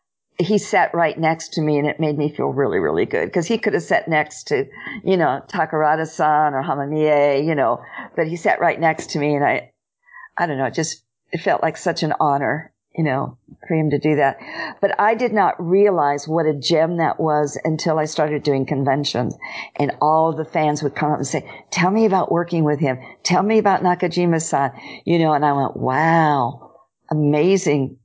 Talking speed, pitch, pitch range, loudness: 205 wpm, 155 Hz, 145-175 Hz, -19 LUFS